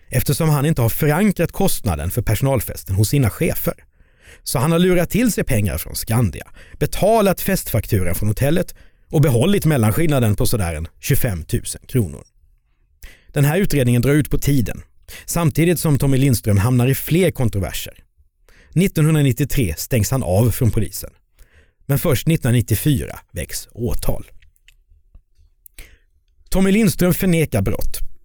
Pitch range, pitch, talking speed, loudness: 95-155 Hz, 125 Hz, 130 wpm, -18 LUFS